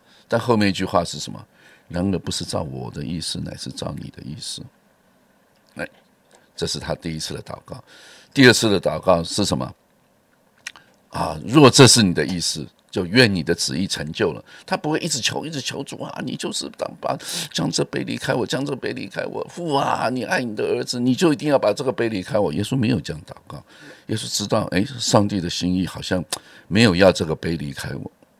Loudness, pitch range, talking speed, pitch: -21 LUFS, 85-120 Hz, 295 characters per minute, 95 Hz